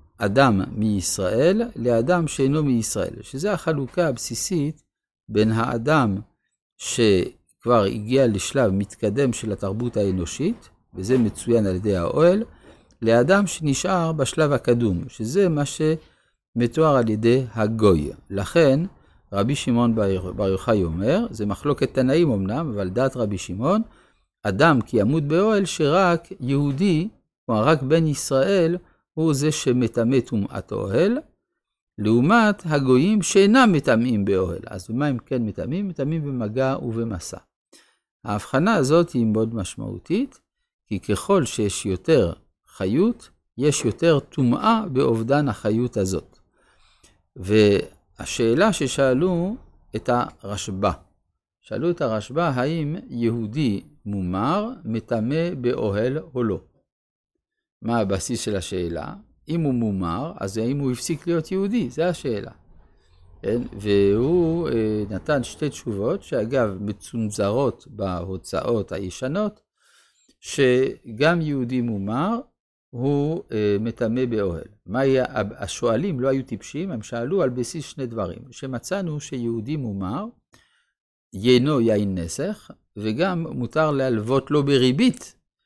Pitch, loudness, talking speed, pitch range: 120 Hz, -22 LUFS, 110 wpm, 105-155 Hz